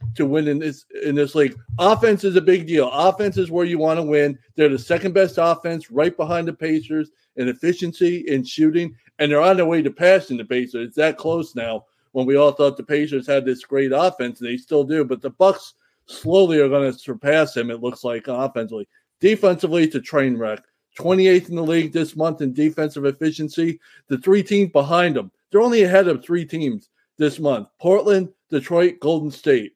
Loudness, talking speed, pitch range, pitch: -19 LUFS, 205 wpm, 140-175 Hz, 155 Hz